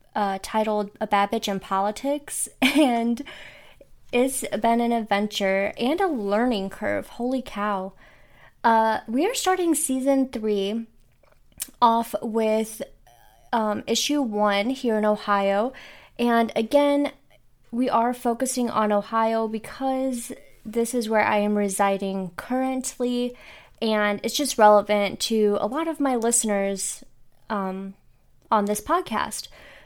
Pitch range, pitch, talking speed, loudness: 205-260 Hz, 225 Hz, 120 wpm, -23 LUFS